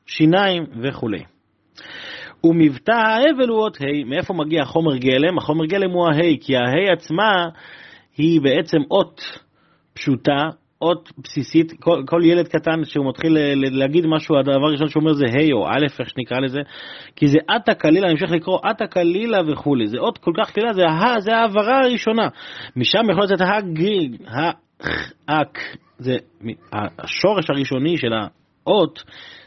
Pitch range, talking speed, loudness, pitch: 145-185 Hz, 155 wpm, -18 LUFS, 160 Hz